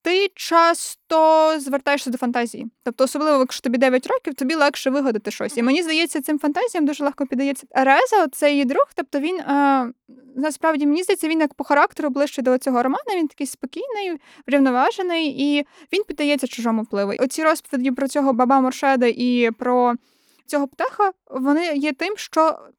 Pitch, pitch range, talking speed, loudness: 285 Hz, 260-320 Hz, 165 wpm, -20 LUFS